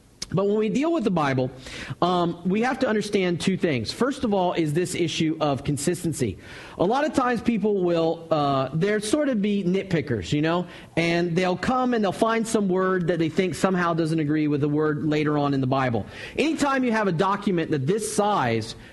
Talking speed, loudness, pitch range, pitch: 220 wpm, -24 LUFS, 150-205 Hz, 175 Hz